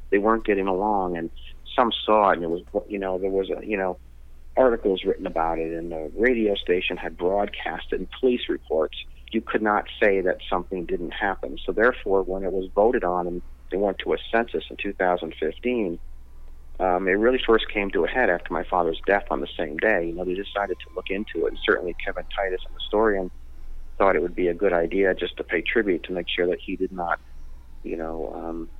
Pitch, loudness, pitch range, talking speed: 90 Hz, -24 LUFS, 75-100 Hz, 225 wpm